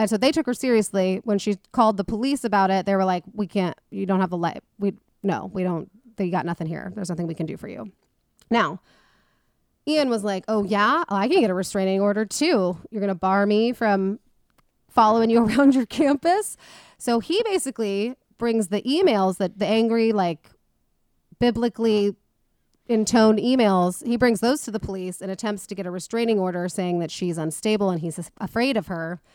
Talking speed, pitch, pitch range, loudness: 200 wpm, 205 Hz, 190-230 Hz, -23 LUFS